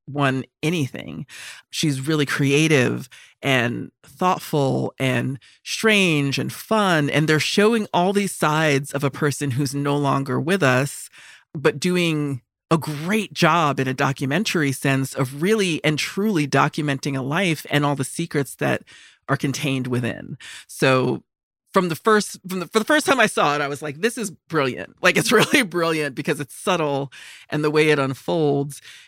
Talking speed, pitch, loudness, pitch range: 165 wpm, 150 Hz, -21 LUFS, 140-170 Hz